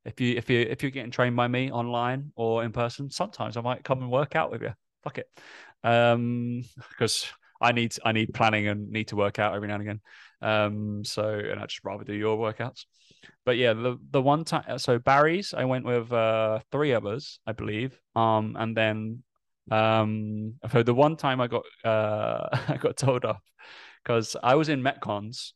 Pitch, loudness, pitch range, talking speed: 115 Hz, -27 LUFS, 110-125 Hz, 205 wpm